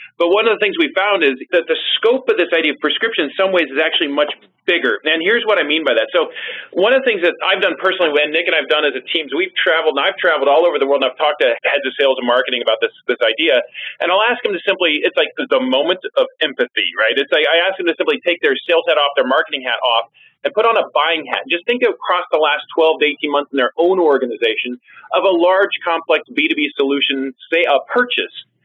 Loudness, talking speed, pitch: -15 LUFS, 275 wpm, 190 Hz